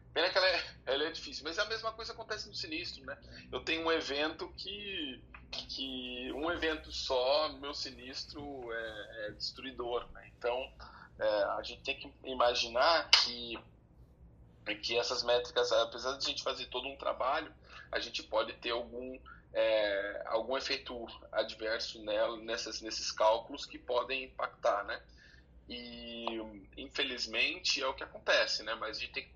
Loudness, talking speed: -35 LUFS, 165 wpm